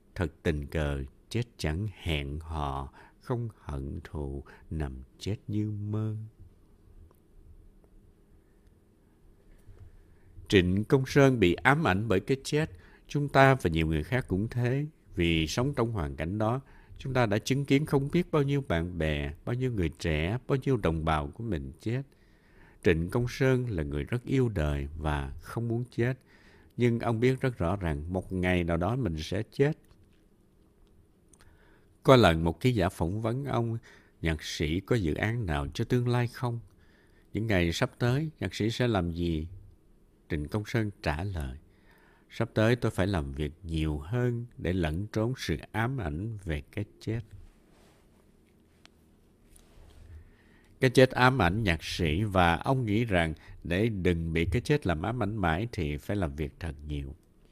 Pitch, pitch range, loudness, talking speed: 95 Hz, 80-115 Hz, -29 LUFS, 165 wpm